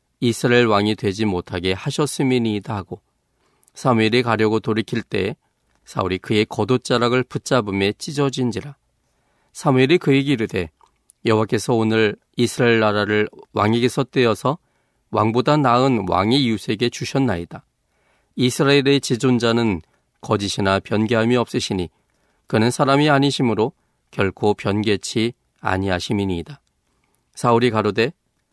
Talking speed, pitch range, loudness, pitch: 305 characters per minute, 105-130 Hz, -19 LUFS, 115 Hz